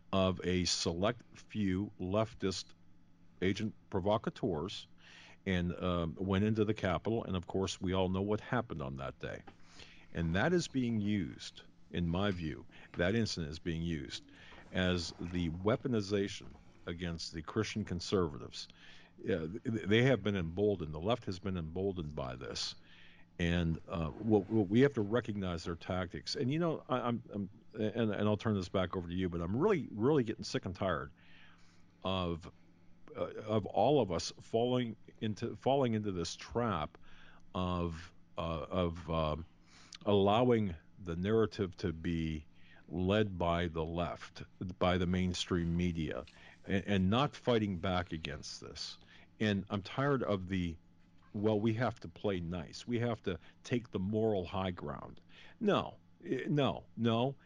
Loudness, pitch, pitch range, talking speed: -36 LUFS, 90 Hz, 85-105 Hz, 155 wpm